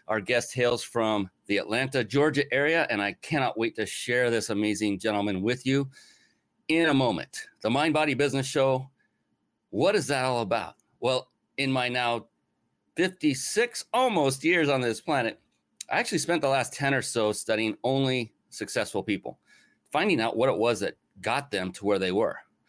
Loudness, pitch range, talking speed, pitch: -27 LUFS, 110-140 Hz, 175 wpm, 130 Hz